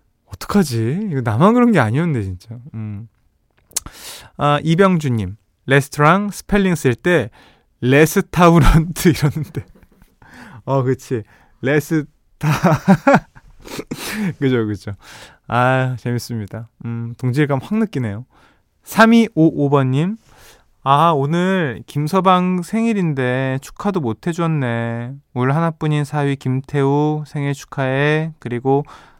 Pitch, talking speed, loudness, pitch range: 140 Hz, 220 characters per minute, -17 LUFS, 120-165 Hz